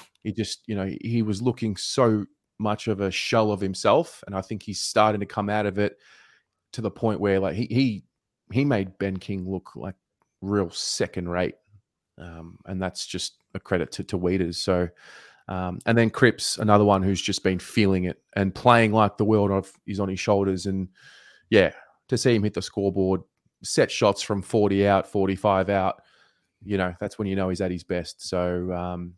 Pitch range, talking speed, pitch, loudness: 95-105 Hz, 200 wpm, 100 Hz, -24 LUFS